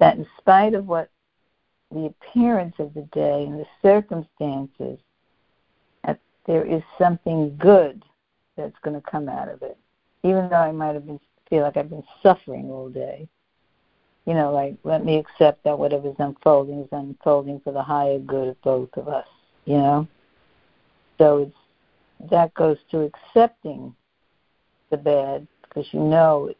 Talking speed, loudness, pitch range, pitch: 160 wpm, -21 LUFS, 145-165 Hz, 150 Hz